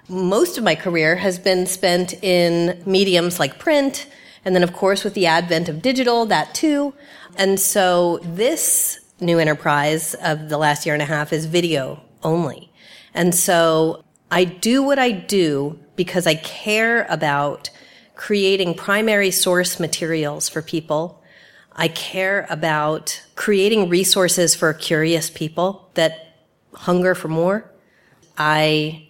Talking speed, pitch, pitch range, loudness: 140 wpm, 175 Hz, 160-195 Hz, -18 LUFS